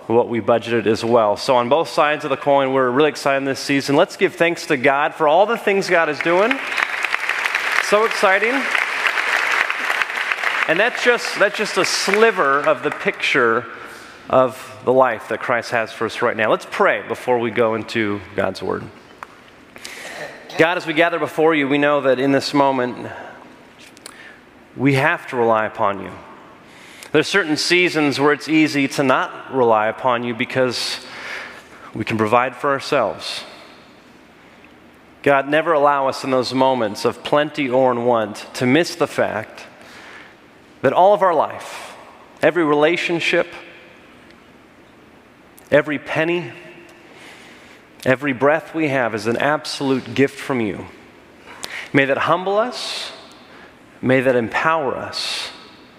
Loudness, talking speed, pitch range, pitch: -18 LUFS, 150 wpm, 125-160 Hz, 140 Hz